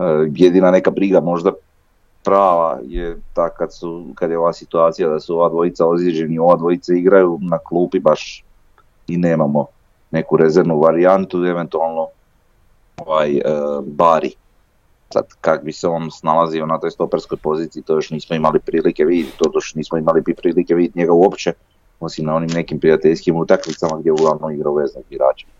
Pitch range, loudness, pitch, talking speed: 80-85 Hz, -16 LUFS, 85 Hz, 160 wpm